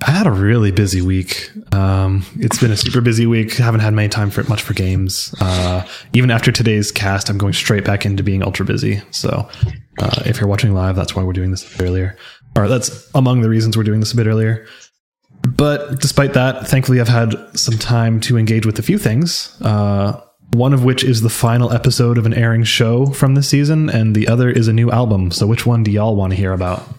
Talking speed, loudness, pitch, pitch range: 240 wpm, -15 LUFS, 110 Hz, 100-125 Hz